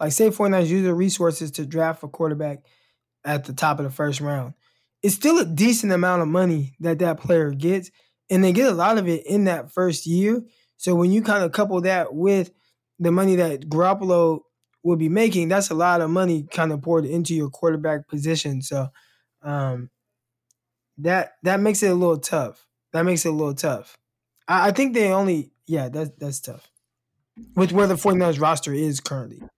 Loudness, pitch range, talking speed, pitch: -21 LUFS, 145-185 Hz, 195 wpm, 165 Hz